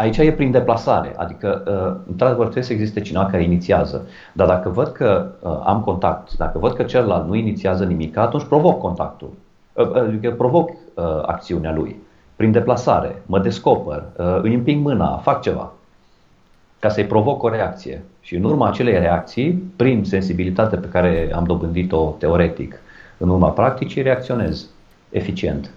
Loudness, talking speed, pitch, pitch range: -19 LUFS, 145 wpm, 105 Hz, 90-125 Hz